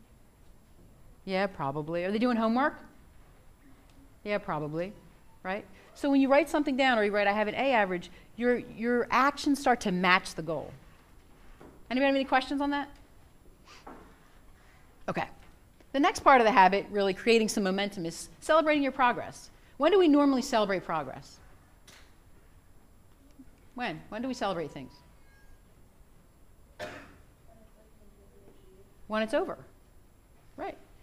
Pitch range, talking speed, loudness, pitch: 160-265 Hz, 130 wpm, -28 LUFS, 205 Hz